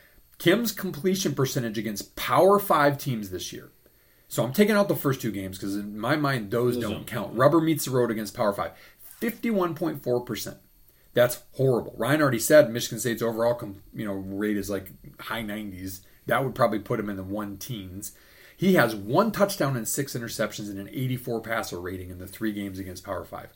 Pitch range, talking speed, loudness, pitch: 105-145 Hz, 195 wpm, -26 LUFS, 120 Hz